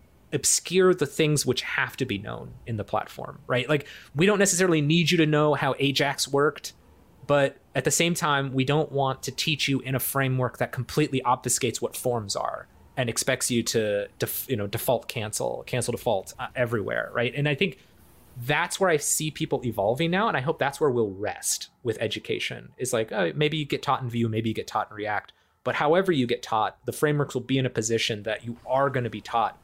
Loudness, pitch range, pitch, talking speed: -25 LUFS, 120-150 Hz, 135 Hz, 220 wpm